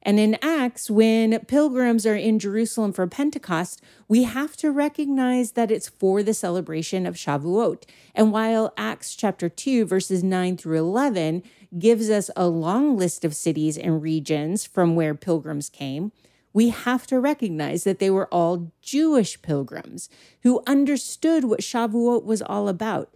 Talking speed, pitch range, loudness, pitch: 155 wpm, 175-240 Hz, -22 LUFS, 210 Hz